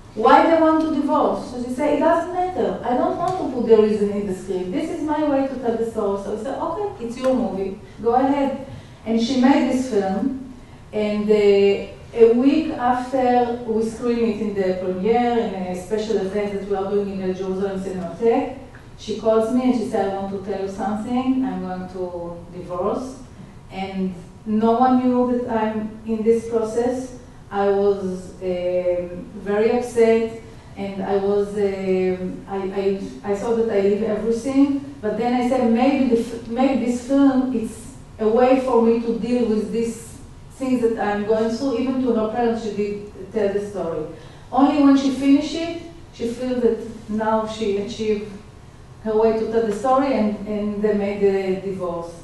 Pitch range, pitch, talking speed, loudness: 200-250 Hz, 225 Hz, 190 wpm, -21 LUFS